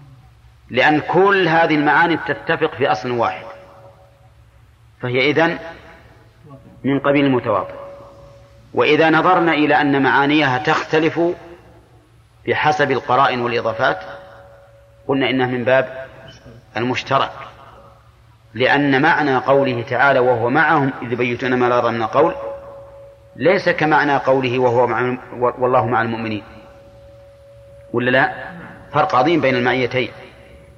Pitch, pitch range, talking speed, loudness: 125 Hz, 110-140 Hz, 105 wpm, -16 LUFS